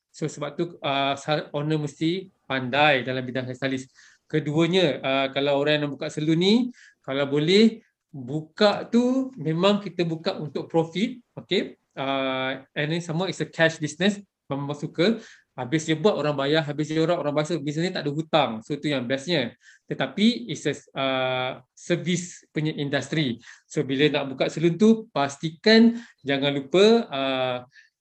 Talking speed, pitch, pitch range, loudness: 165 wpm, 155 Hz, 140-175 Hz, -24 LUFS